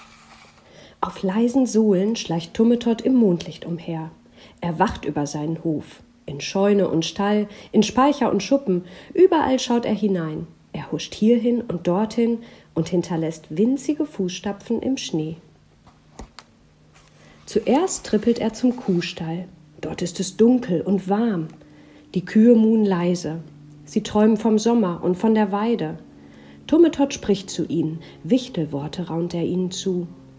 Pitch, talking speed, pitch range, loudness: 185 Hz, 135 wpm, 160-225 Hz, -21 LUFS